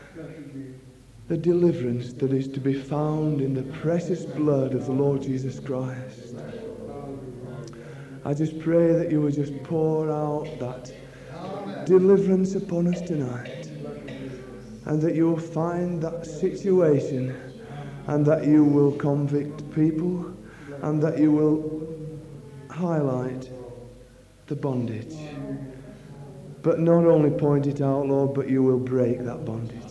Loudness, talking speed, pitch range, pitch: -24 LUFS, 125 wpm, 130-160 Hz, 145 Hz